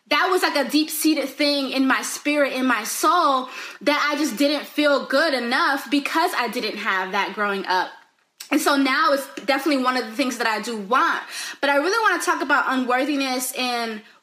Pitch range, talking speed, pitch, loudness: 245-295 Hz, 200 wpm, 270 Hz, -21 LUFS